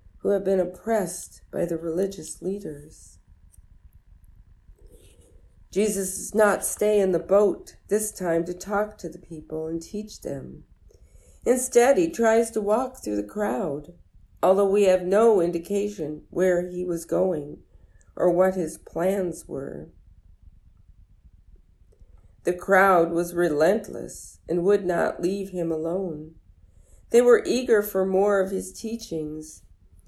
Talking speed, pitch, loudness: 130 wpm, 175 Hz, -24 LUFS